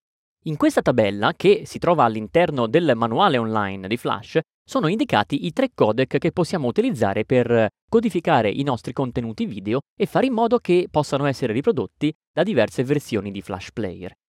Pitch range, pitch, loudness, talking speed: 110-175 Hz, 140 Hz, -21 LUFS, 170 wpm